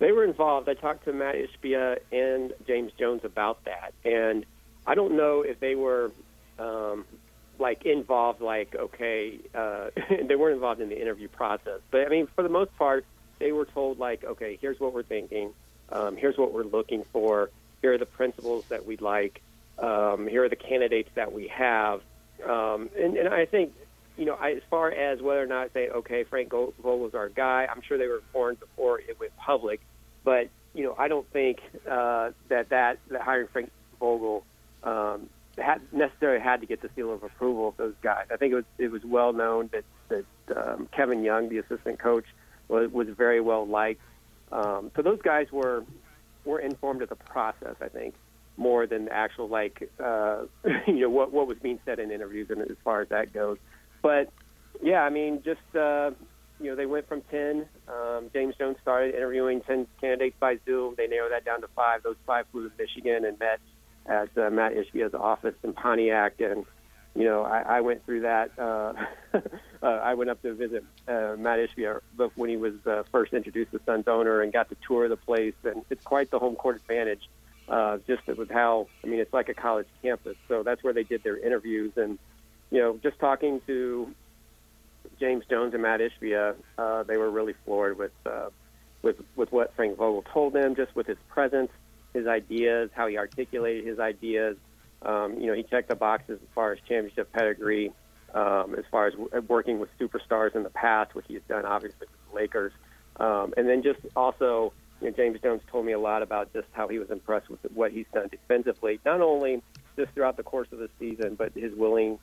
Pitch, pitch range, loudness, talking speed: 120 Hz, 110-140 Hz, -28 LUFS, 205 wpm